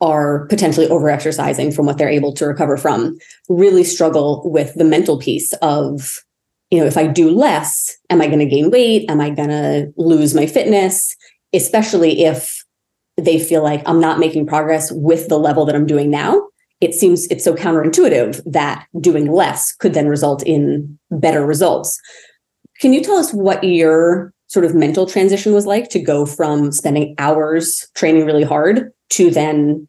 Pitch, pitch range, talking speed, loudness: 160 Hz, 150-180 Hz, 175 wpm, -14 LUFS